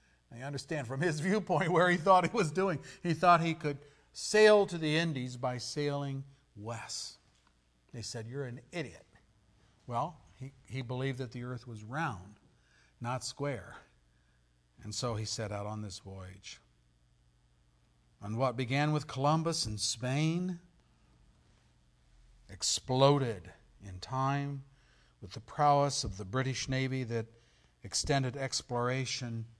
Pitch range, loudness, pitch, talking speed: 105-145 Hz, -32 LUFS, 125 Hz, 135 wpm